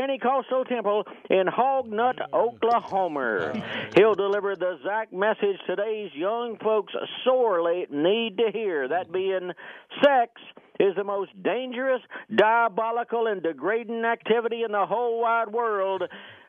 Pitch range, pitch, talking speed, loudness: 200-240 Hz, 225 Hz, 120 wpm, -25 LUFS